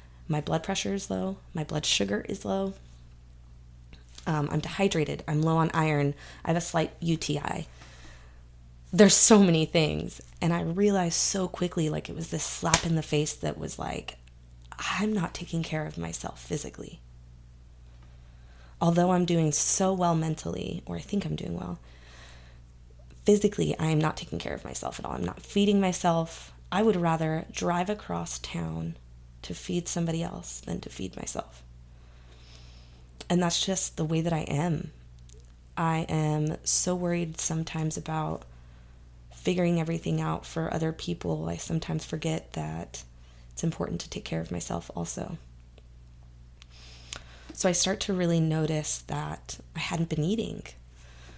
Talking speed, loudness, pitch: 155 wpm, -28 LUFS, 100 Hz